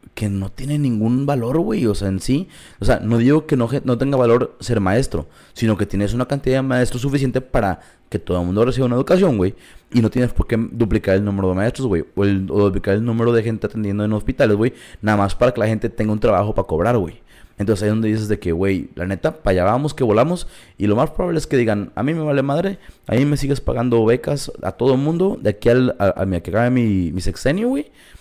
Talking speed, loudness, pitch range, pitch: 255 wpm, -19 LUFS, 100-130 Hz, 115 Hz